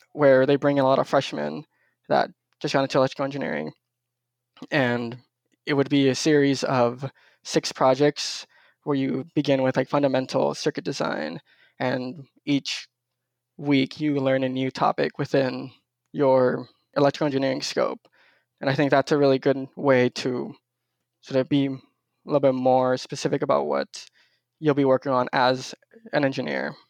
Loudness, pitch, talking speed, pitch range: -23 LUFS, 135 Hz, 155 wpm, 130-140 Hz